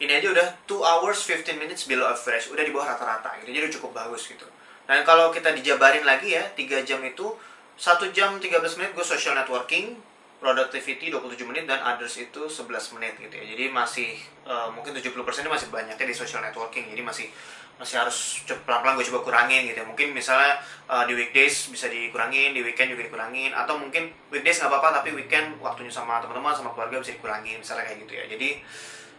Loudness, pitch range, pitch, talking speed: -24 LUFS, 120-165 Hz, 135 Hz, 200 wpm